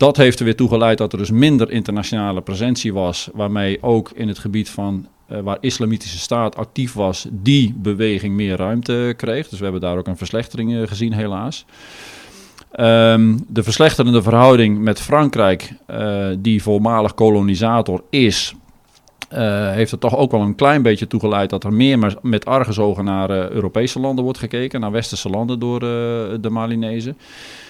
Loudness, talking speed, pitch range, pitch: -17 LUFS, 175 wpm, 100-120 Hz, 110 Hz